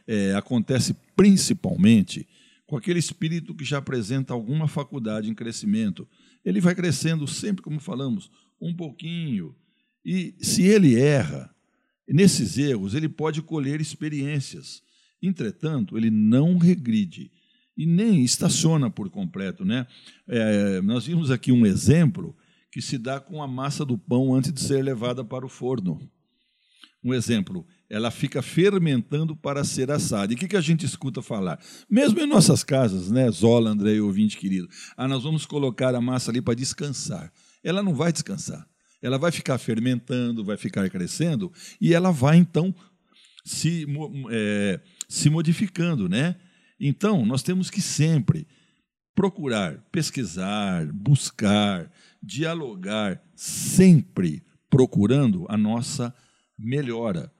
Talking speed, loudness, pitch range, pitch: 135 wpm, -23 LUFS, 125-180 Hz, 150 Hz